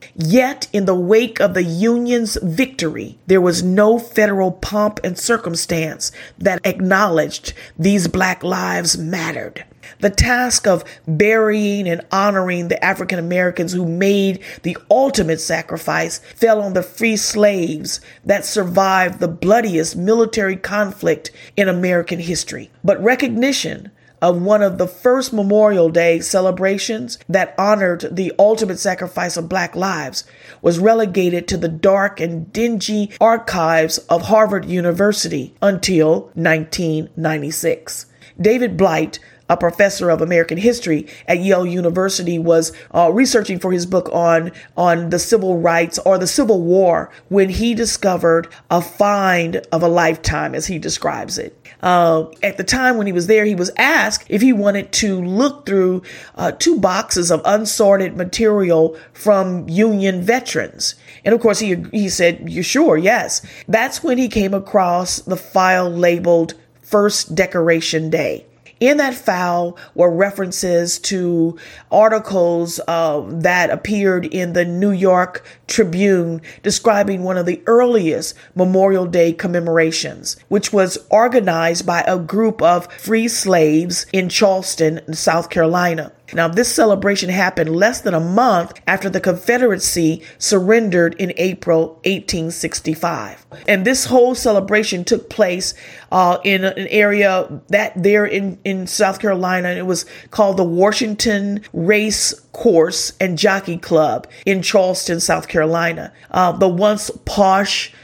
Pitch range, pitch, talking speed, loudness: 170-210 Hz, 185 Hz, 140 wpm, -16 LUFS